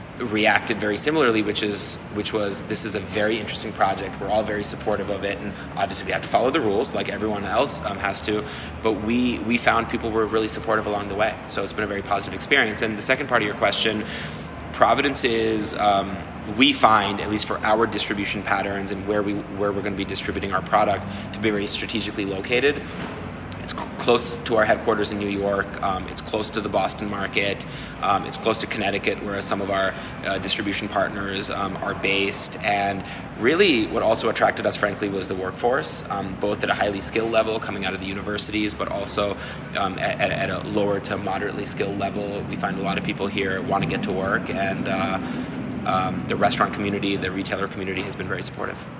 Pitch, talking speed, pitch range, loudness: 100 Hz, 210 wpm, 100-110 Hz, -23 LUFS